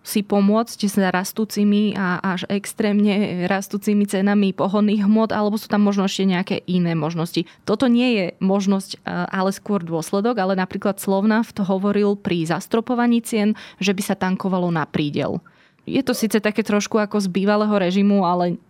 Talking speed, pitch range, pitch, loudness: 165 wpm, 190-210 Hz, 200 Hz, -20 LUFS